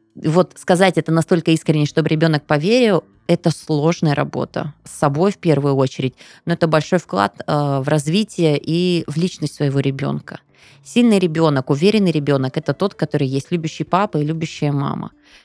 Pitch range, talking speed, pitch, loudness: 145-175 Hz, 155 wpm, 160 Hz, -18 LUFS